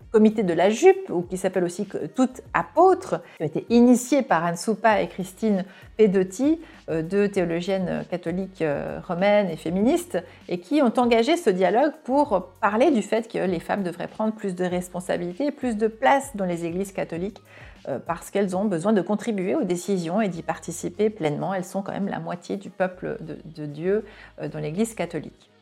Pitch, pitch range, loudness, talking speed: 195 Hz, 180-225 Hz, -24 LUFS, 180 wpm